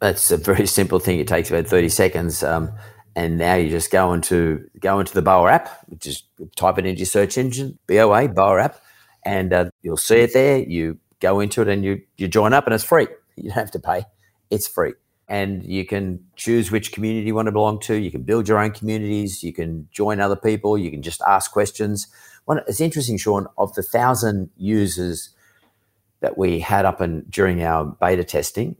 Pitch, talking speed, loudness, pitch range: 100 Hz, 210 wpm, -20 LUFS, 90-110 Hz